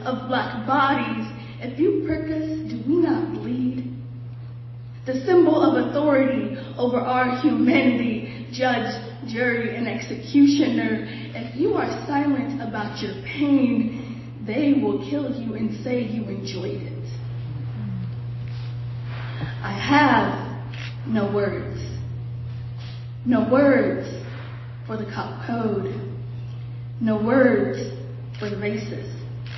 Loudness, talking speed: -23 LUFS, 110 wpm